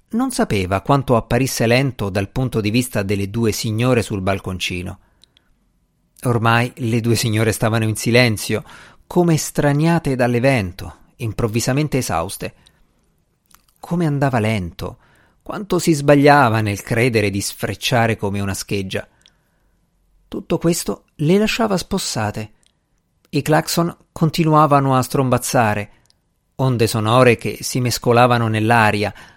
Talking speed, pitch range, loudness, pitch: 110 wpm, 105-140 Hz, -18 LUFS, 115 Hz